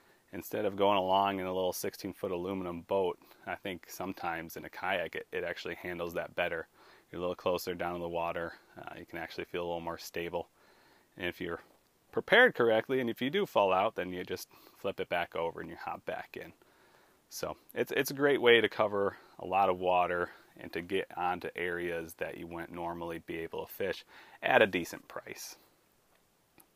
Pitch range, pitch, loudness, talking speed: 85-100 Hz, 90 Hz, -33 LUFS, 210 wpm